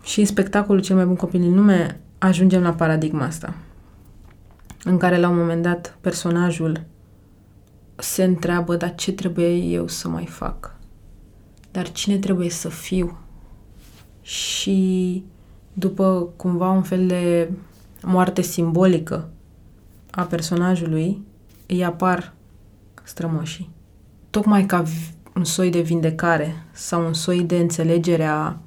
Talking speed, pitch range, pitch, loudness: 125 wpm, 150-185 Hz, 170 Hz, -21 LUFS